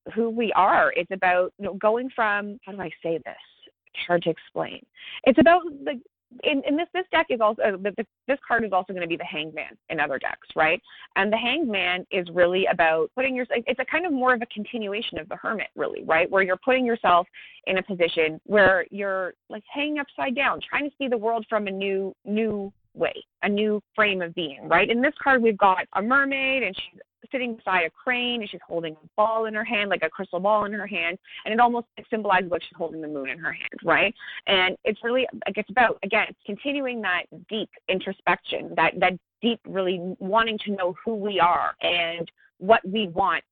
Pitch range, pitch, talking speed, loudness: 180-235 Hz, 205 Hz, 220 wpm, -24 LUFS